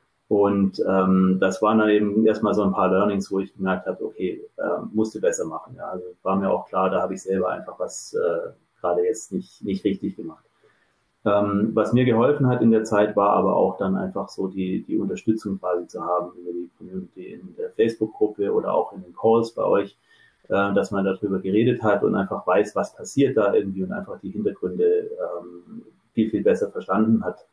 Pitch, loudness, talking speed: 110 Hz, -23 LUFS, 205 wpm